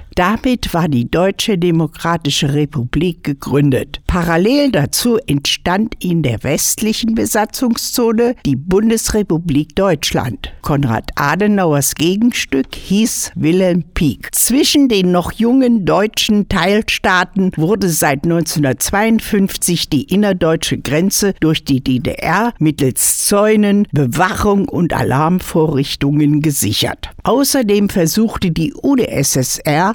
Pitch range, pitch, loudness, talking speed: 150-210 Hz, 175 Hz, -14 LUFS, 95 wpm